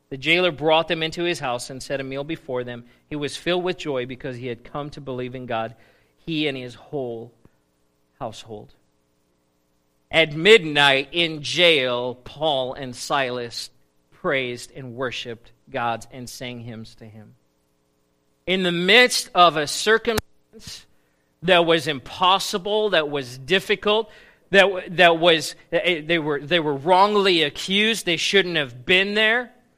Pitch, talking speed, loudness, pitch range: 145 Hz, 145 wpm, -20 LUFS, 120-175 Hz